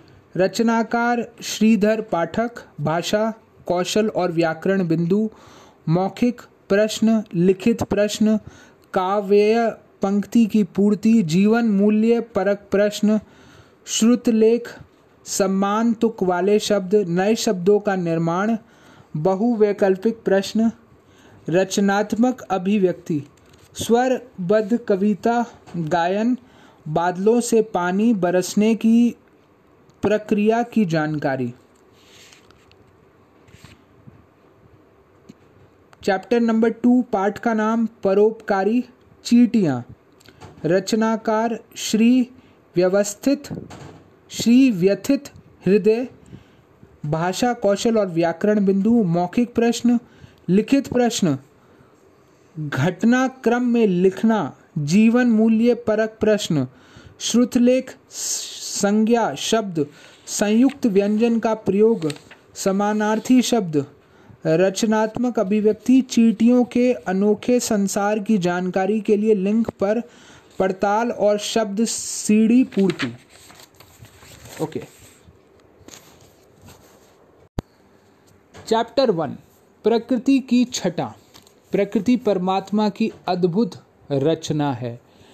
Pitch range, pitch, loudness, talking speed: 185-230 Hz, 210 Hz, -20 LUFS, 80 wpm